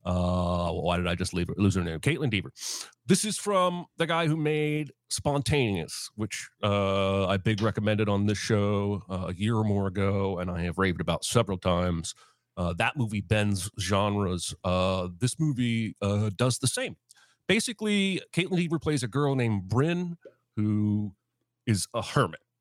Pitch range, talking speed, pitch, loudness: 95-135 Hz, 175 wpm, 105 Hz, -28 LUFS